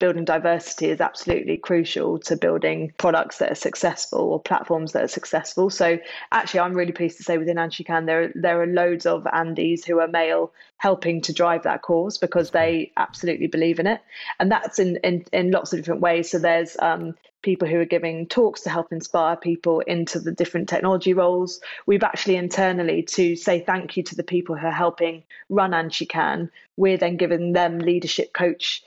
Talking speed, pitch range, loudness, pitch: 195 wpm, 165-180 Hz, -22 LUFS, 170 Hz